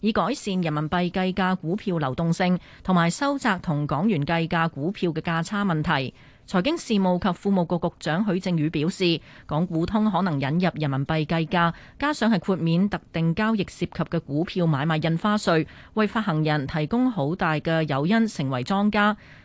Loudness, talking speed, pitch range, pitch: -24 LUFS, 280 characters per minute, 160-200 Hz, 175 Hz